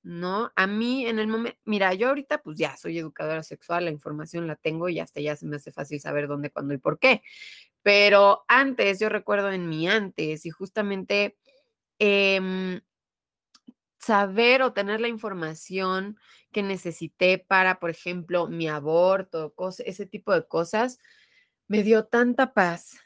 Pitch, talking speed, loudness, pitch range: 190 Hz, 160 wpm, -24 LUFS, 165-215 Hz